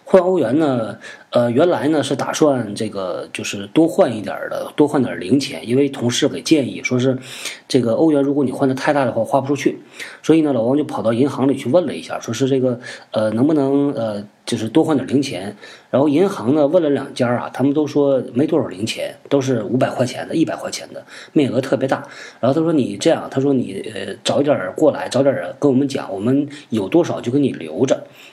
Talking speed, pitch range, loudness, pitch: 320 characters per minute, 125-145 Hz, -18 LUFS, 135 Hz